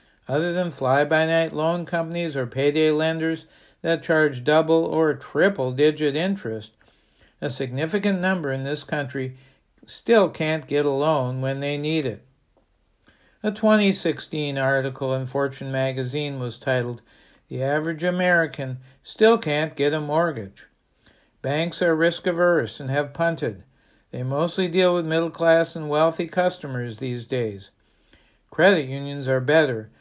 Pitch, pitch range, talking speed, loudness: 150 Hz, 135-165 Hz, 130 wpm, -23 LUFS